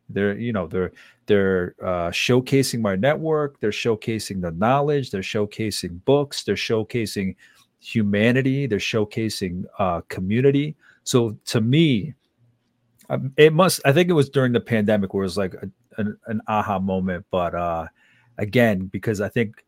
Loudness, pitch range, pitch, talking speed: -22 LUFS, 100-130 Hz, 110 Hz, 150 wpm